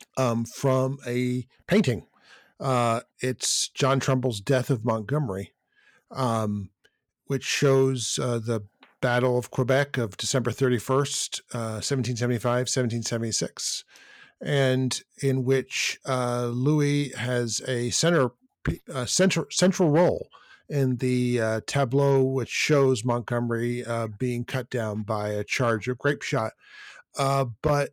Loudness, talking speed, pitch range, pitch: -26 LUFS, 120 wpm, 120-135 Hz, 125 Hz